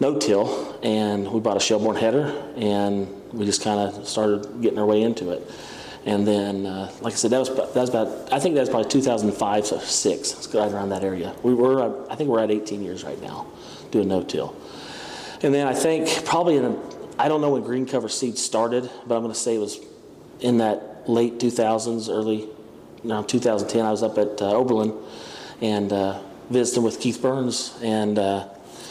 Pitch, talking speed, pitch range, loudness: 110 Hz, 205 wpm, 105-120 Hz, -23 LUFS